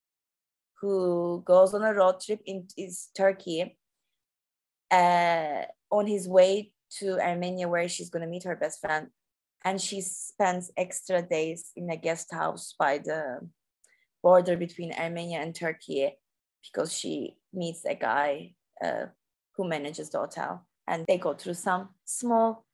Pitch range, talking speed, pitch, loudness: 170-195 Hz, 140 wpm, 180 Hz, -28 LUFS